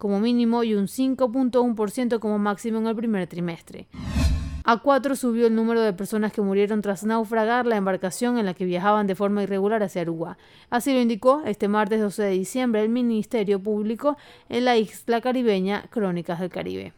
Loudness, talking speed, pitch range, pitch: -23 LUFS, 180 wpm, 200-235 Hz, 215 Hz